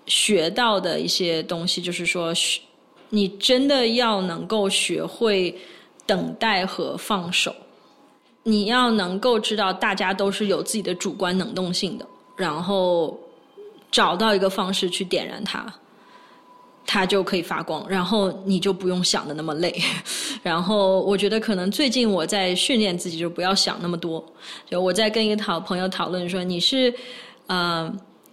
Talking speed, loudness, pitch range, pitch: 230 characters per minute, -22 LUFS, 180-215 Hz, 195 Hz